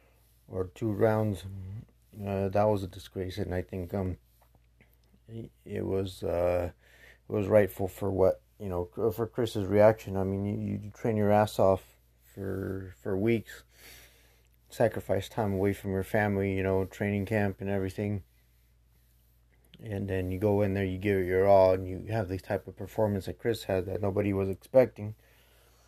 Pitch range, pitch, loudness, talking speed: 90-105 Hz, 95 Hz, -30 LUFS, 170 wpm